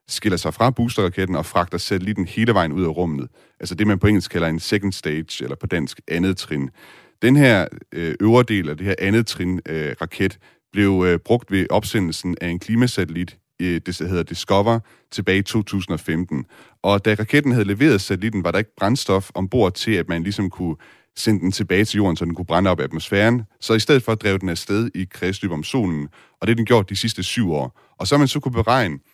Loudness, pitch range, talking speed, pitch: -20 LUFS, 85-110 Hz, 210 wpm, 95 Hz